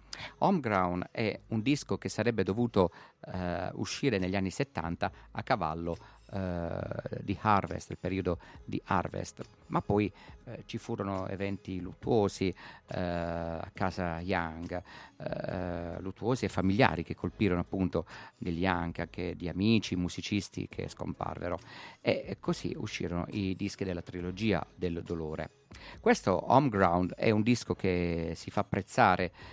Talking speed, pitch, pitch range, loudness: 130 wpm, 90 Hz, 85-100 Hz, -32 LUFS